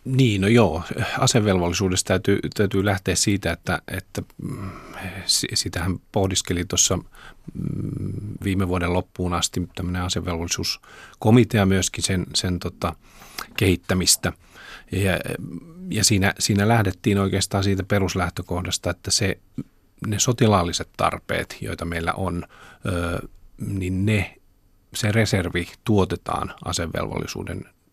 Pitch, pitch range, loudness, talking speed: 95 Hz, 90-105 Hz, -22 LUFS, 100 wpm